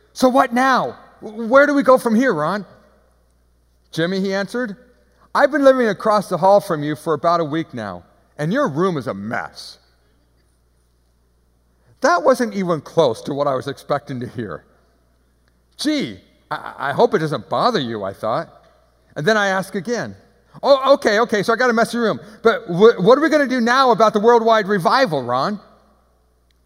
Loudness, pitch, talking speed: -17 LUFS, 190 Hz, 180 wpm